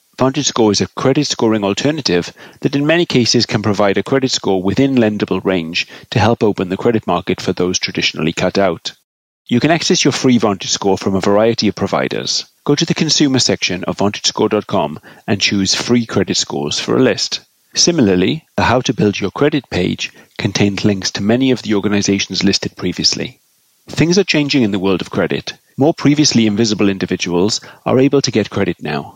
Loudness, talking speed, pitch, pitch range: -15 LUFS, 190 wpm, 105 Hz, 95-130 Hz